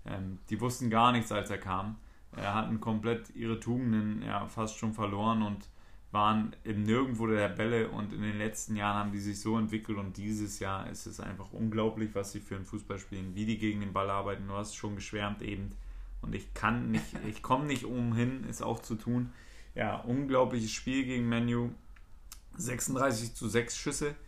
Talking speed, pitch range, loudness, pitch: 195 wpm, 100-115 Hz, -34 LUFS, 110 Hz